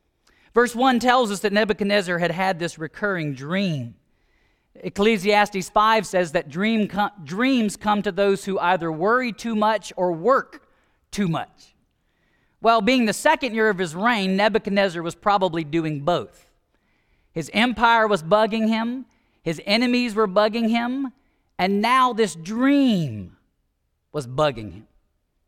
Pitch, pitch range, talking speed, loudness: 205 Hz, 165-225 Hz, 140 wpm, -21 LUFS